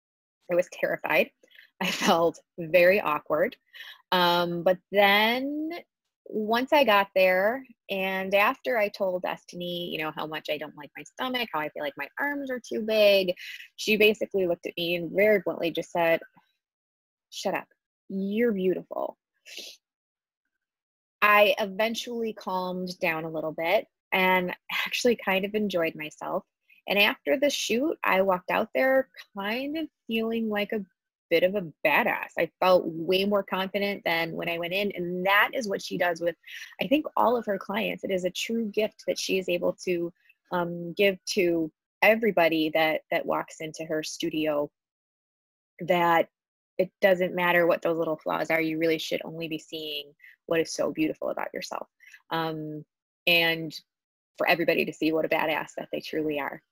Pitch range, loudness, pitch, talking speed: 165-210 Hz, -26 LUFS, 185 Hz, 165 wpm